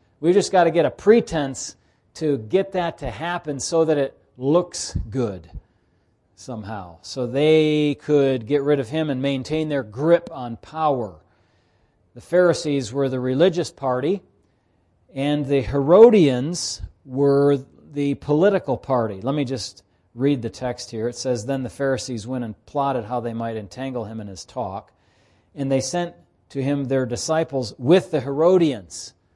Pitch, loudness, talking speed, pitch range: 135 Hz, -21 LUFS, 155 wpm, 115-150 Hz